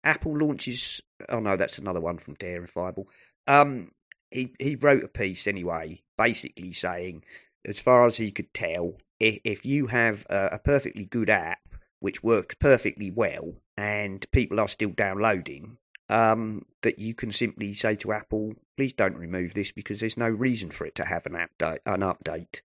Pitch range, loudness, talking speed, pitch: 95-120 Hz, -27 LUFS, 170 wpm, 105 Hz